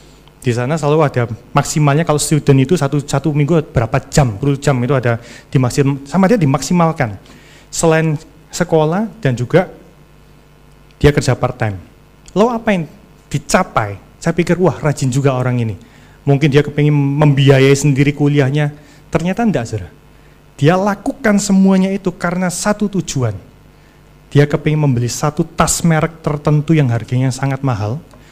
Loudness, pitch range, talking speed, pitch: -15 LUFS, 135-165 Hz, 140 wpm, 150 Hz